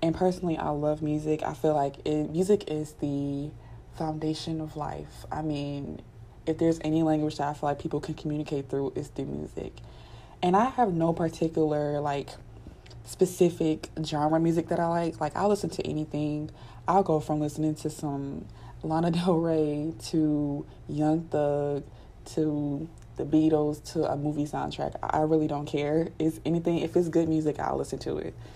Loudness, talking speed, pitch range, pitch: -29 LUFS, 170 wpm, 145-160 Hz, 155 Hz